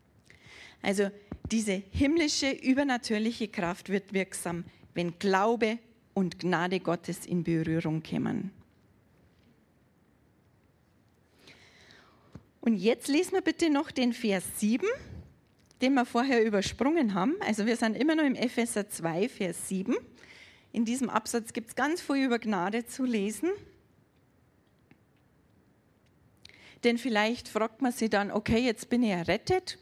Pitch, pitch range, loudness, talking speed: 225 Hz, 195-255 Hz, -30 LUFS, 125 wpm